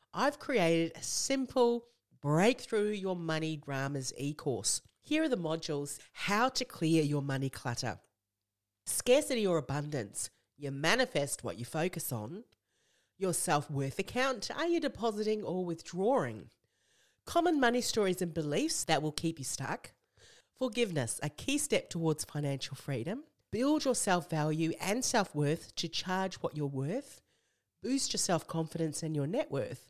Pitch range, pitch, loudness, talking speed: 145-230 Hz, 165 Hz, -33 LUFS, 140 wpm